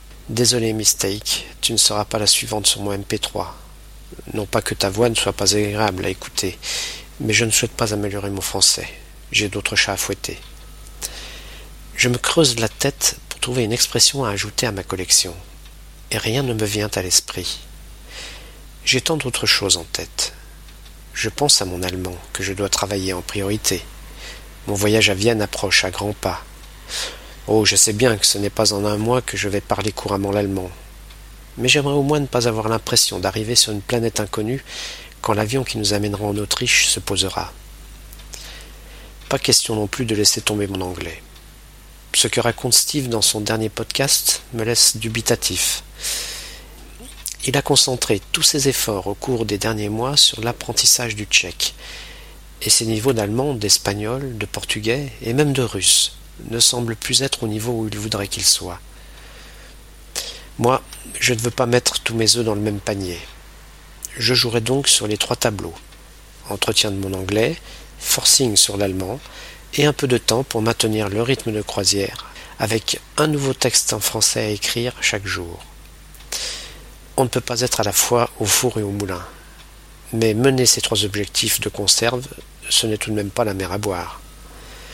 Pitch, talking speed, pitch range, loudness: 110 Hz, 180 wpm, 100-120 Hz, -18 LUFS